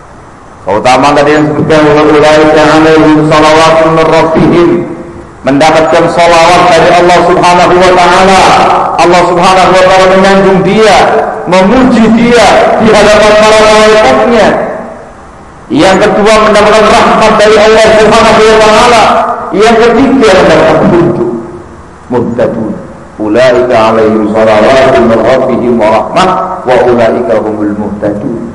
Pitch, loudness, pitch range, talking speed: 175 Hz, -4 LUFS, 150-210 Hz, 105 wpm